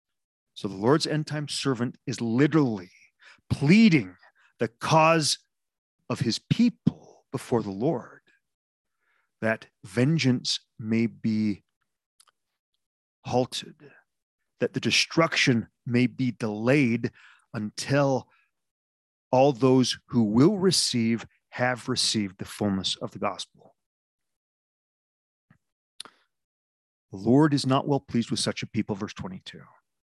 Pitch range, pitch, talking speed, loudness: 110-140 Hz, 125 Hz, 105 wpm, -25 LUFS